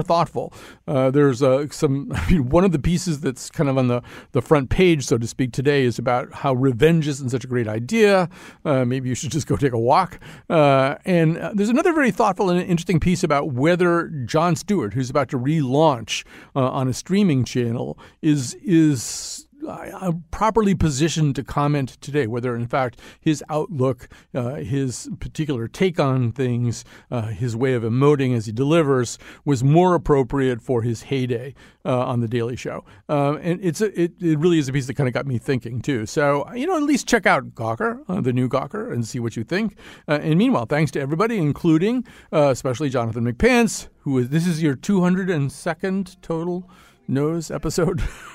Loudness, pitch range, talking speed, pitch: -21 LUFS, 130-170 Hz, 190 wpm, 145 Hz